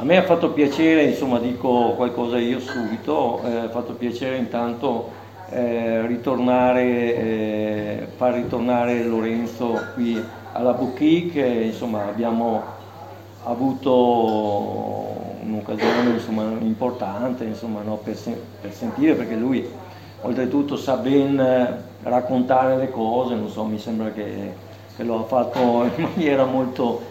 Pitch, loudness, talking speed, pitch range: 120 Hz, -22 LUFS, 125 wpm, 110-125 Hz